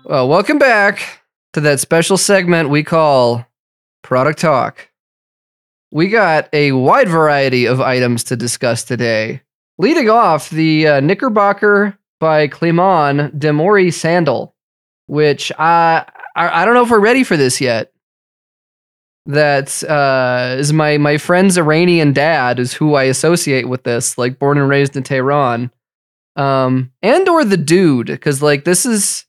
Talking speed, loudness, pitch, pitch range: 145 wpm, -13 LUFS, 150 Hz, 130-170 Hz